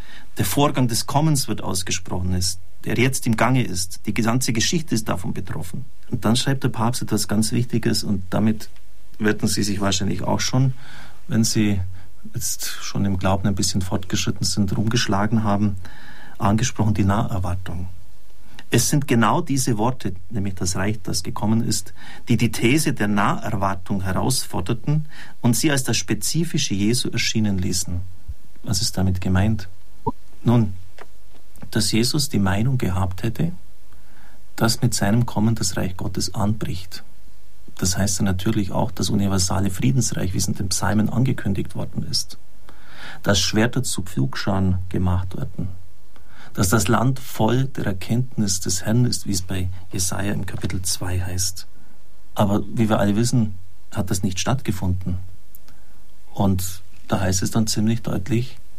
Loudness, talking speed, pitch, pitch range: -22 LUFS, 150 wpm, 105 Hz, 95-115 Hz